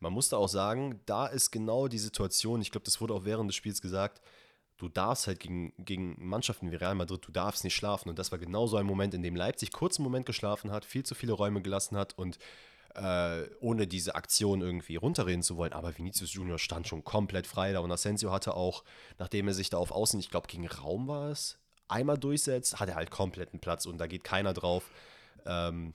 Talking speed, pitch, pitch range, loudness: 230 wpm, 95 Hz, 90-110 Hz, -33 LUFS